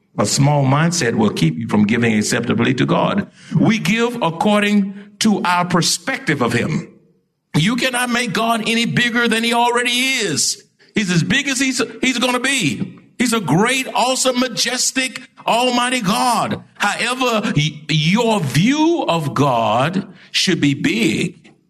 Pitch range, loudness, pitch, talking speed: 170-245 Hz, -17 LUFS, 215 Hz, 145 wpm